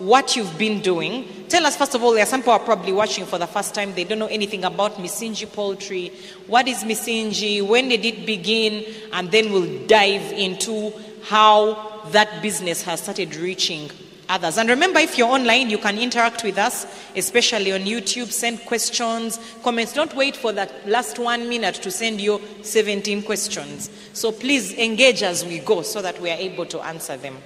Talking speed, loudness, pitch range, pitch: 195 wpm, -20 LUFS, 195-230 Hz, 215 Hz